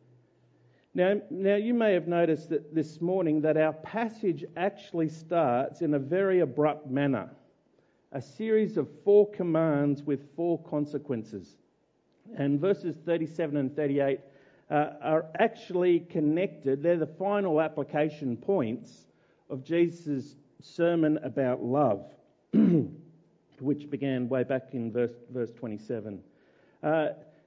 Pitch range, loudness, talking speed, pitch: 140-170 Hz, -29 LUFS, 120 wpm, 155 Hz